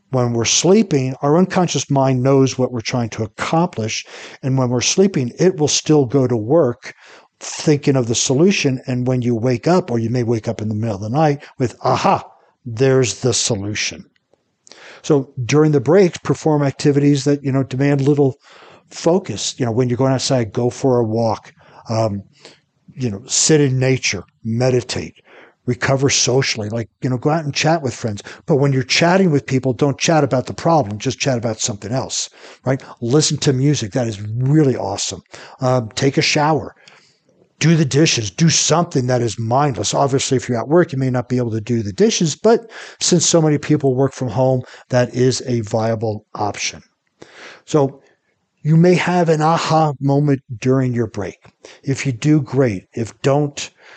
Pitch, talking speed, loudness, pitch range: 130 Hz, 185 wpm, -17 LUFS, 120-145 Hz